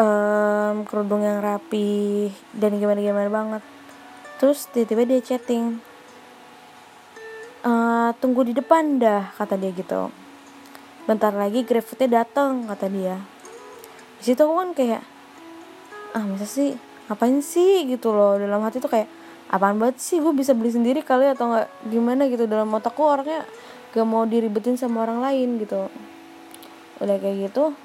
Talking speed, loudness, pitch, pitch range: 140 wpm, -22 LUFS, 230 Hz, 210-265 Hz